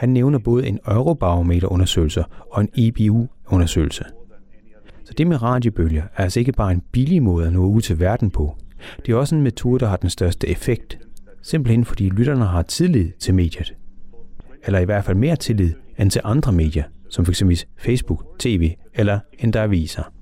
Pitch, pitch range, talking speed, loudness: 100 Hz, 90-120 Hz, 175 wpm, -19 LUFS